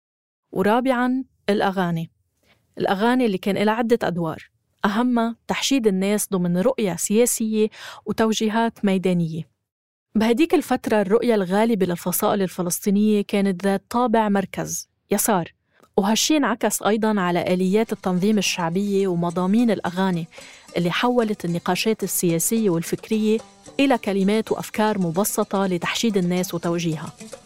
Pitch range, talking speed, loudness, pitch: 180-225 Hz, 105 wpm, -21 LUFS, 200 Hz